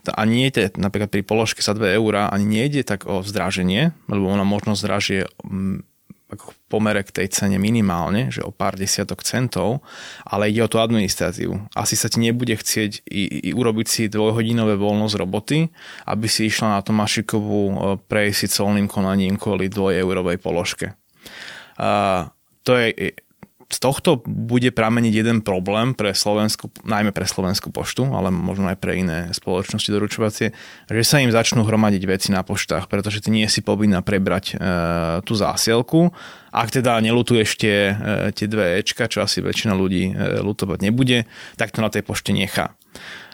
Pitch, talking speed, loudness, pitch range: 105 Hz, 165 wpm, -20 LUFS, 95-110 Hz